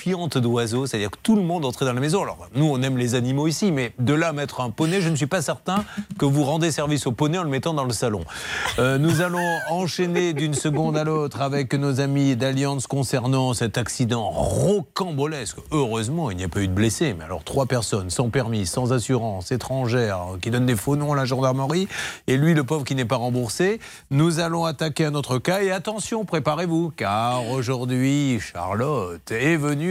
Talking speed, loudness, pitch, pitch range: 210 wpm, -23 LUFS, 140 Hz, 125-165 Hz